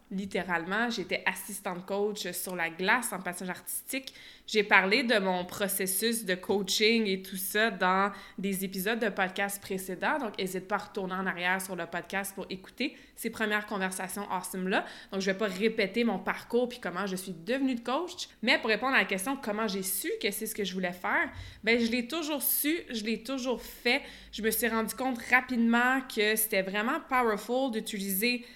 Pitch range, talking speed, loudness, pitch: 190-240 Hz, 195 wpm, -30 LUFS, 210 Hz